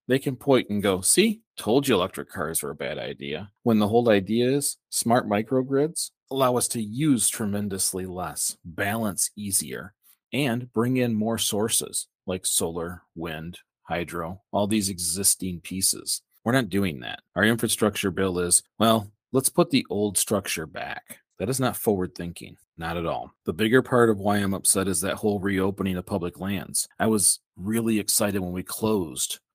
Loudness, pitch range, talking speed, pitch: -24 LUFS, 95-115 Hz, 175 wpm, 105 Hz